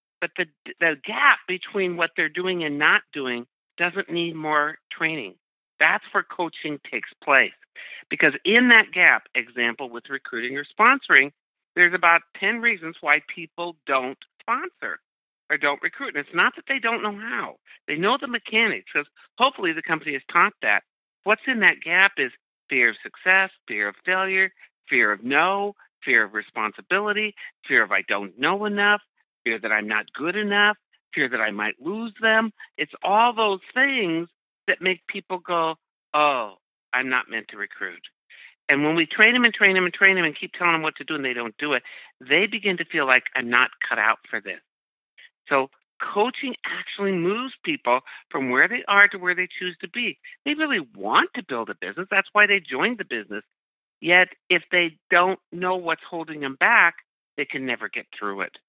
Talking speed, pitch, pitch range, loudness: 190 wpm, 180 Hz, 155-210 Hz, -21 LUFS